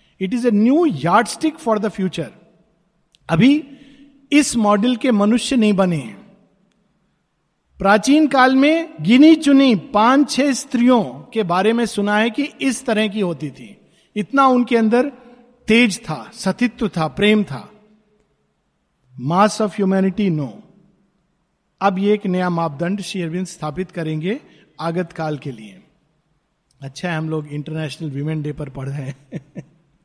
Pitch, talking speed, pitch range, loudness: 200 Hz, 140 wpm, 165-235 Hz, -17 LUFS